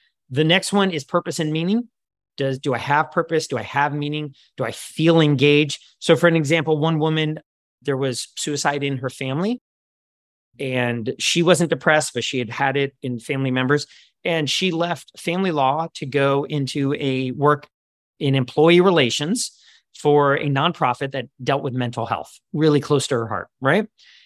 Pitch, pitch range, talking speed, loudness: 145 Hz, 135-160 Hz, 175 wpm, -20 LUFS